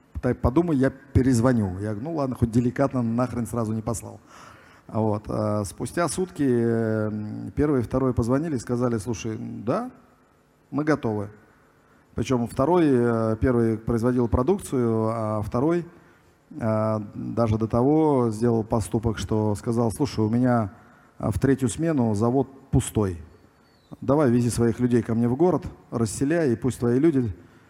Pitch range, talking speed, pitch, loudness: 110-130 Hz, 135 wpm, 120 Hz, -24 LUFS